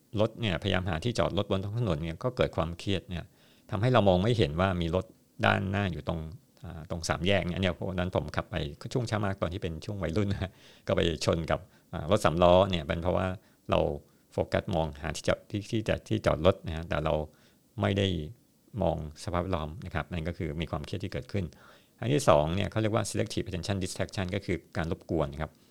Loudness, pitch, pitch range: -30 LUFS, 90 Hz, 80-100 Hz